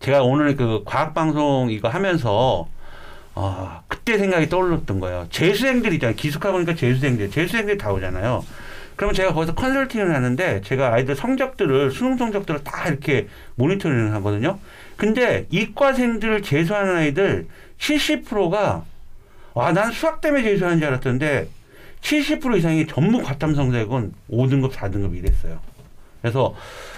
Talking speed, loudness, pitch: 330 characters per minute, -21 LUFS, 150 Hz